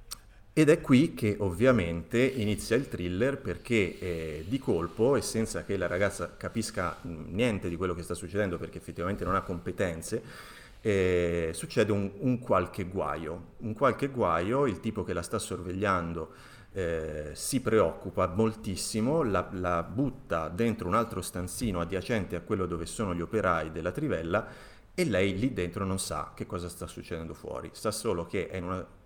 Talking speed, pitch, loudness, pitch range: 165 wpm, 95 Hz, -30 LUFS, 90-110 Hz